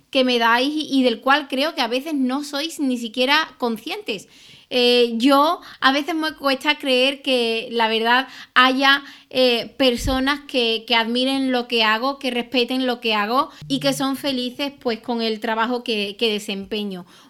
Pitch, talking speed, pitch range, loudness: 255 Hz, 175 wpm, 235-275 Hz, -20 LUFS